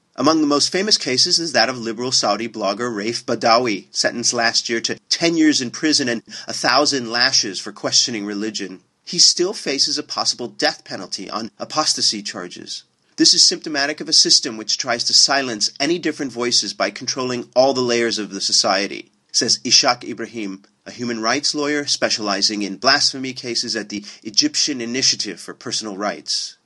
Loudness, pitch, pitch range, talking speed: -17 LUFS, 120 Hz, 110-145 Hz, 175 wpm